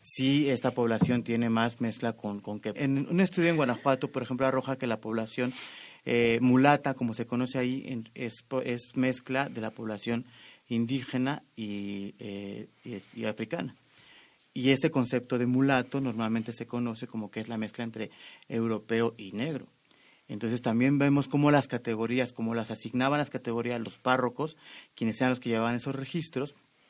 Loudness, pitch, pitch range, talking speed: -30 LUFS, 120 Hz, 115-130 Hz, 165 wpm